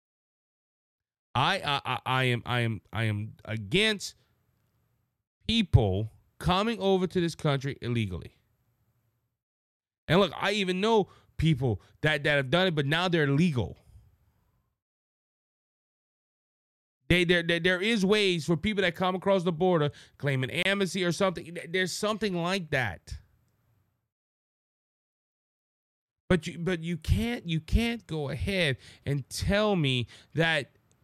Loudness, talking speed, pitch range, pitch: -28 LUFS, 125 wpm, 115-185 Hz, 145 Hz